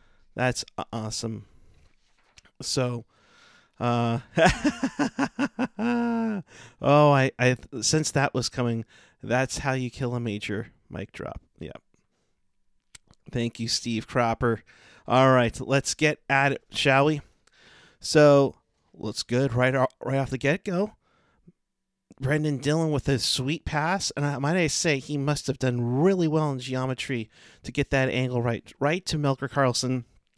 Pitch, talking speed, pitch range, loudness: 135 Hz, 140 wpm, 120-150 Hz, -25 LUFS